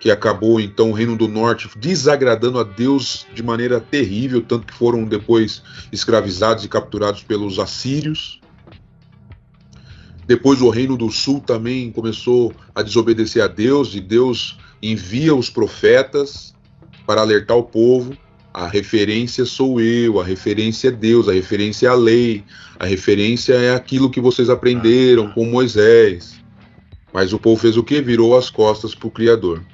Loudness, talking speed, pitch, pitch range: -16 LUFS, 155 wpm, 115 Hz, 110-125 Hz